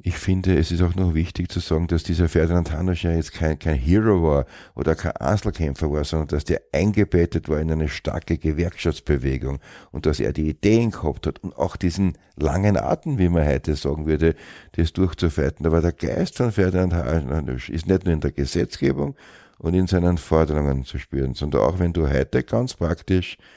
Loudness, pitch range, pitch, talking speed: -22 LUFS, 75-90 Hz, 85 Hz, 195 wpm